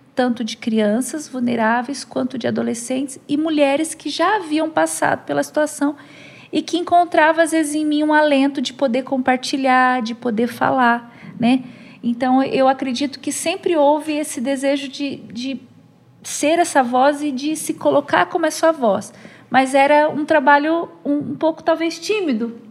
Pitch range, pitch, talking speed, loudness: 255-310 Hz, 280 Hz, 165 wpm, -18 LUFS